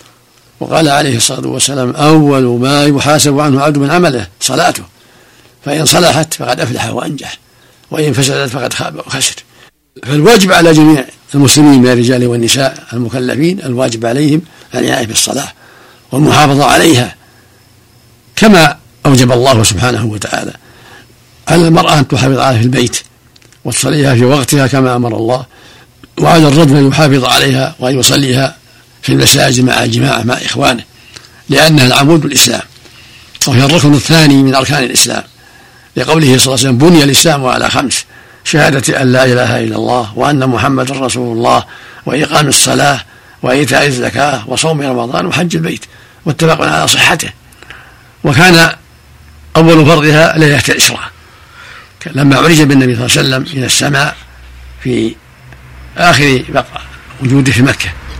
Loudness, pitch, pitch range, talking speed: -9 LUFS, 130 Hz, 120-150 Hz, 130 wpm